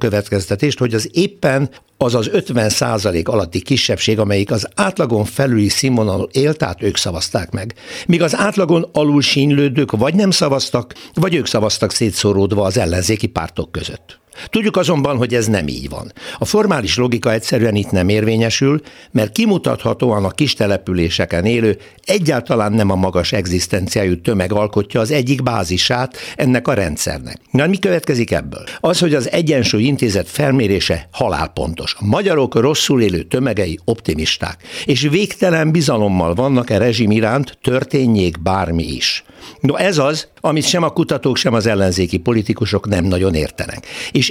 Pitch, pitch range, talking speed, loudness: 115 Hz, 100-145 Hz, 150 wpm, -16 LUFS